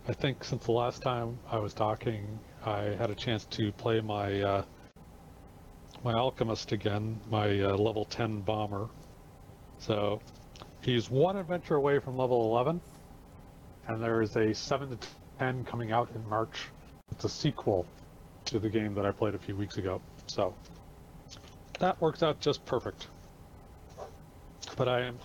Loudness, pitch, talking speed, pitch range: -32 LUFS, 115 Hz, 155 wpm, 105-125 Hz